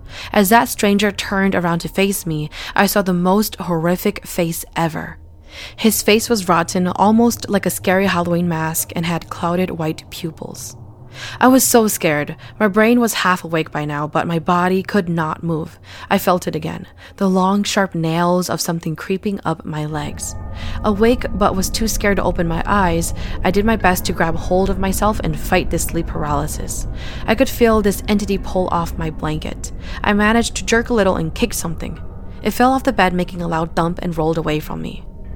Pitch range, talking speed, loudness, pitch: 160-205 Hz, 195 wpm, -18 LUFS, 180 Hz